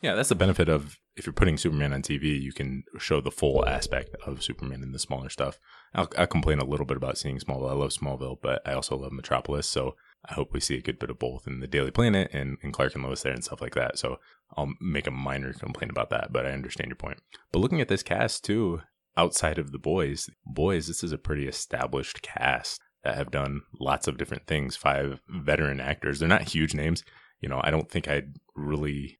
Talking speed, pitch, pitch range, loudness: 235 wpm, 70 Hz, 65-75 Hz, -29 LUFS